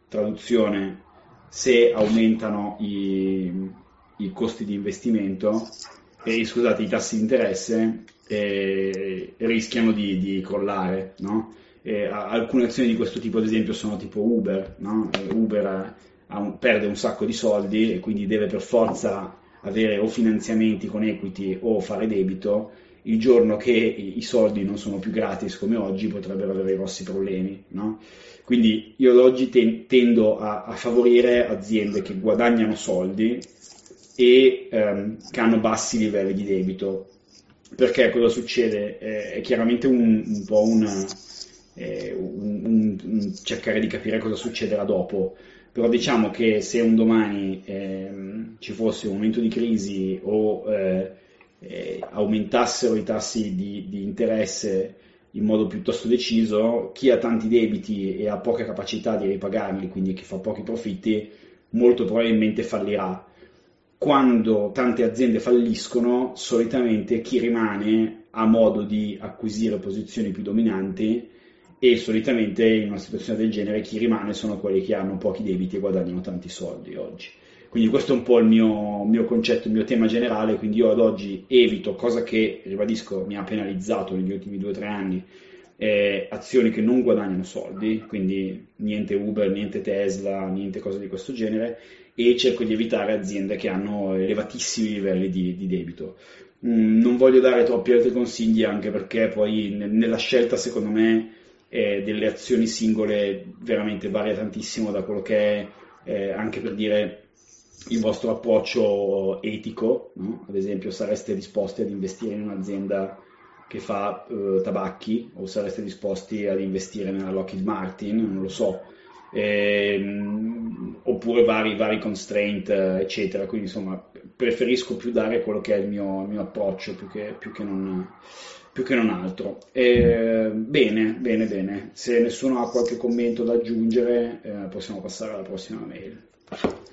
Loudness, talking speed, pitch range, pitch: -23 LUFS, 155 wpm, 100-115 Hz, 110 Hz